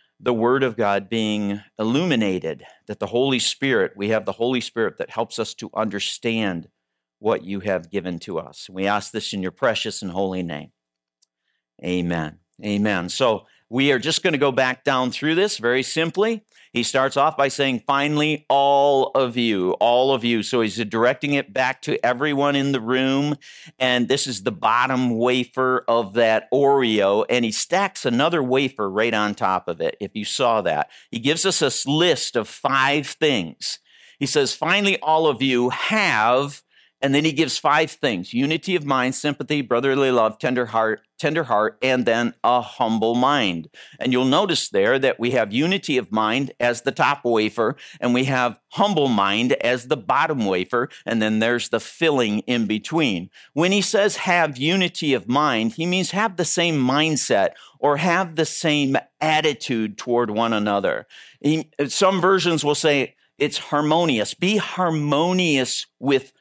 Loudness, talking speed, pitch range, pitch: -21 LUFS, 175 wpm, 110-150 Hz, 130 Hz